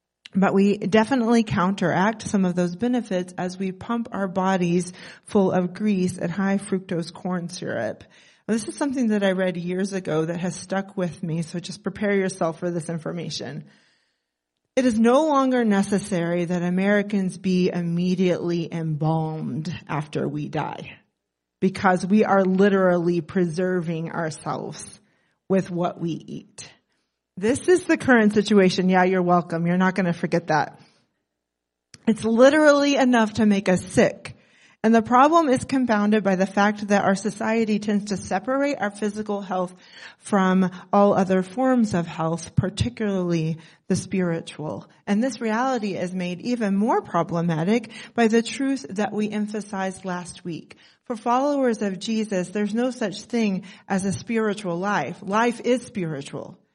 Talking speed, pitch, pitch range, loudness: 150 wpm, 195 Hz, 180-220 Hz, -23 LUFS